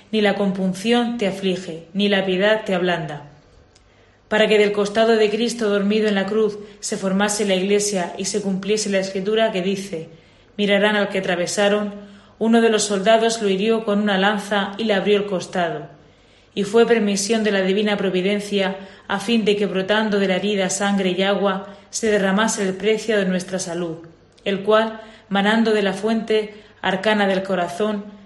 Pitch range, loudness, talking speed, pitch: 190-215 Hz, -20 LUFS, 175 wpm, 205 Hz